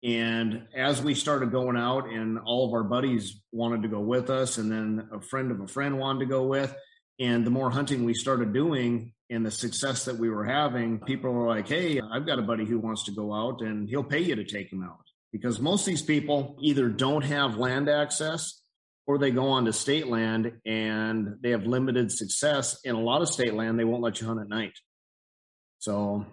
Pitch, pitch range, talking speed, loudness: 120 Hz, 110-135 Hz, 225 wpm, -28 LUFS